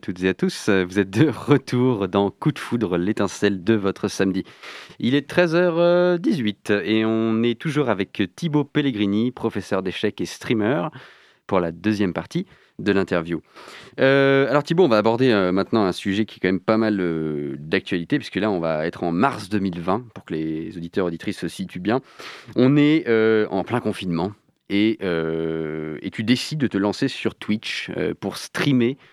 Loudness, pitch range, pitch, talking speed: -22 LUFS, 95-130 Hz, 105 Hz, 185 wpm